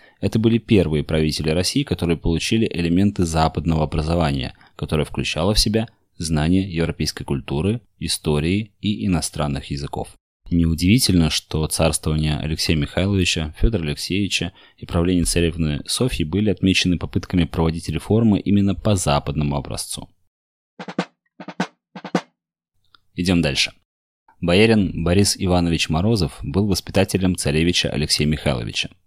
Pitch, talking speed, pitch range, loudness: 85 Hz, 105 wpm, 80-100 Hz, -20 LUFS